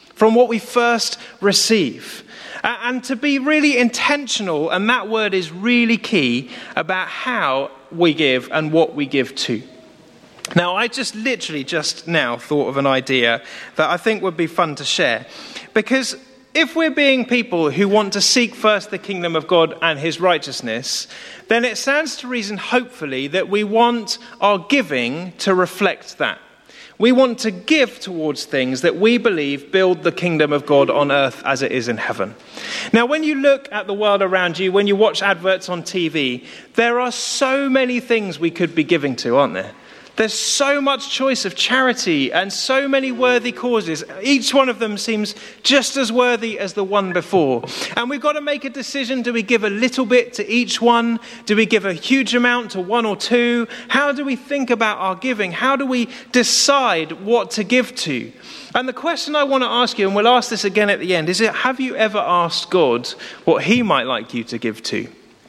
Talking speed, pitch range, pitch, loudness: 200 wpm, 180-250 Hz, 220 Hz, -18 LUFS